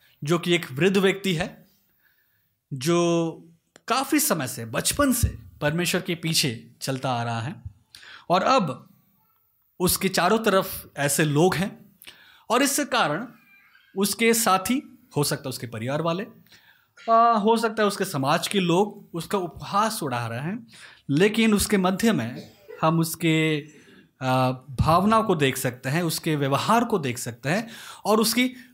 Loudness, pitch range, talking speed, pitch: -23 LUFS, 145-210 Hz, 145 wpm, 180 Hz